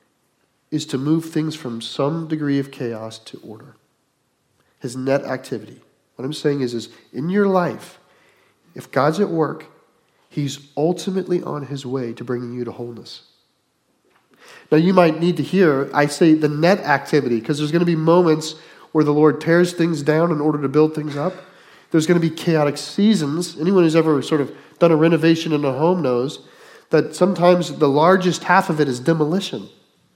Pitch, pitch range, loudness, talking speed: 155 Hz, 140-170 Hz, -19 LUFS, 185 wpm